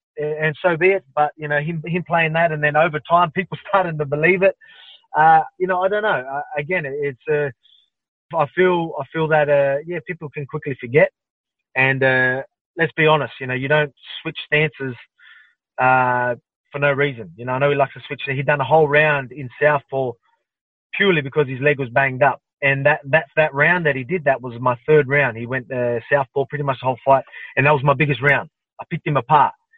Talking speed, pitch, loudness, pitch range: 225 wpm, 150 Hz, -19 LUFS, 135-165 Hz